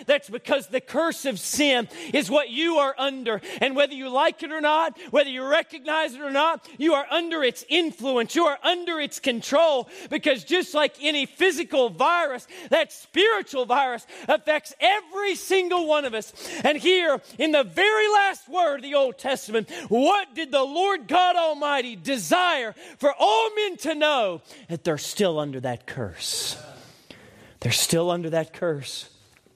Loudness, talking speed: -23 LUFS, 170 wpm